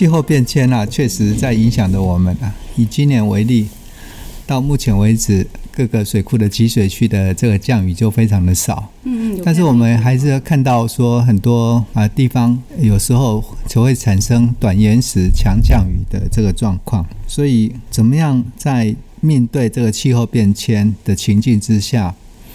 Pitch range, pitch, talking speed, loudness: 105-125 Hz, 115 Hz, 255 characters per minute, -14 LUFS